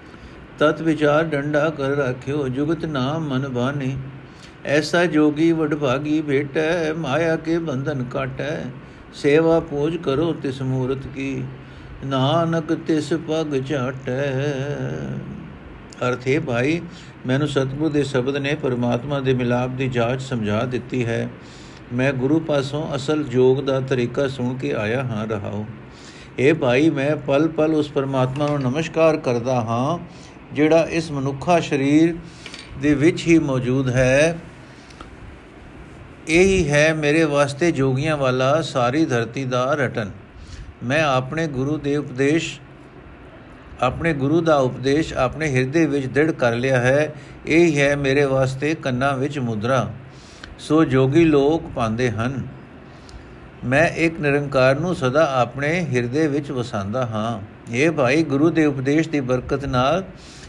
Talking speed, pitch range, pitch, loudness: 130 wpm, 130-155 Hz, 140 Hz, -20 LUFS